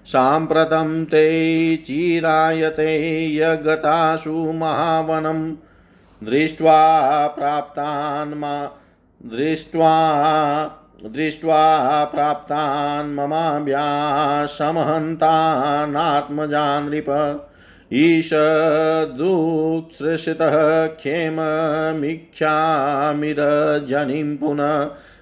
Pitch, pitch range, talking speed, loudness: 155 Hz, 145-160 Hz, 35 wpm, -19 LUFS